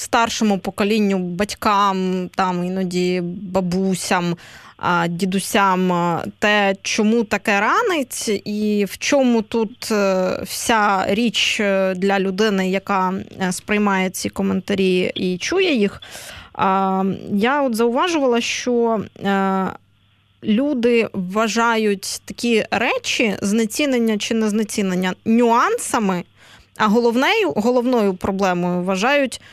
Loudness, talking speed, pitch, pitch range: -19 LUFS, 90 wpm, 205 Hz, 190-230 Hz